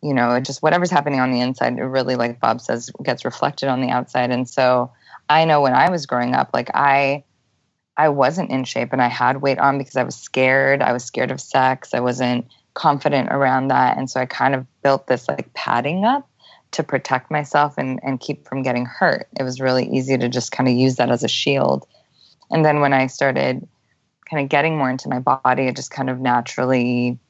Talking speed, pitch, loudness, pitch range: 225 wpm, 130 Hz, -19 LUFS, 125-140 Hz